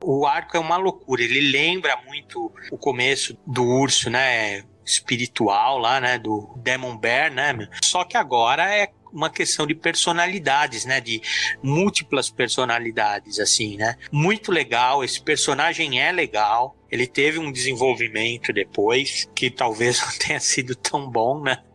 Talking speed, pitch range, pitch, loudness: 145 wpm, 120-165 Hz, 130 Hz, -21 LUFS